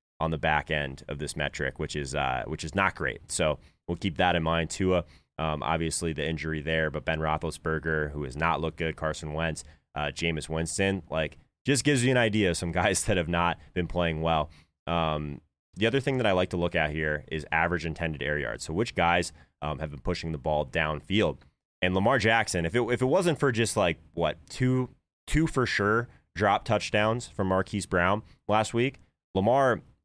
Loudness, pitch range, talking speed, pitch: -28 LUFS, 75-95 Hz, 210 wpm, 85 Hz